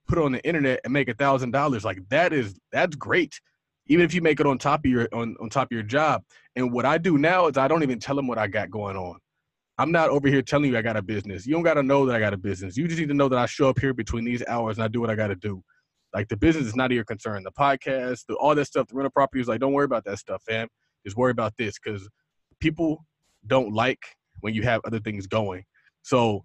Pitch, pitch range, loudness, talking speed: 125 Hz, 110-140 Hz, -24 LUFS, 285 wpm